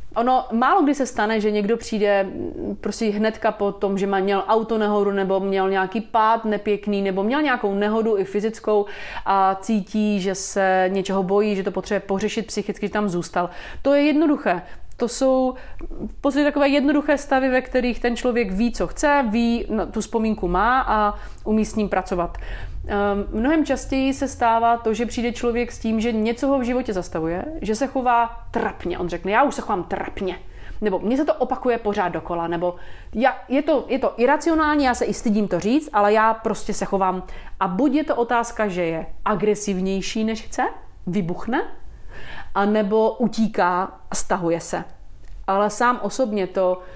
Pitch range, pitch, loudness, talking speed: 195-245 Hz, 215 Hz, -21 LUFS, 180 wpm